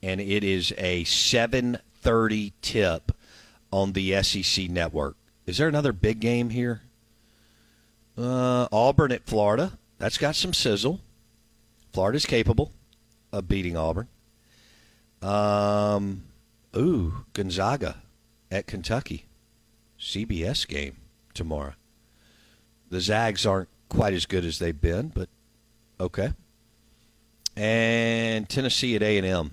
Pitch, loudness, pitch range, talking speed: 110 Hz, -26 LUFS, 95-115 Hz, 105 wpm